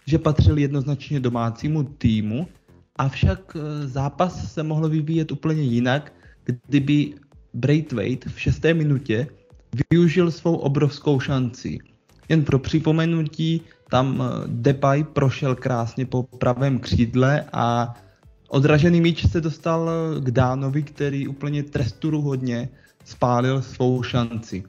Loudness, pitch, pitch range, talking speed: -22 LUFS, 140 Hz, 125-155 Hz, 105 wpm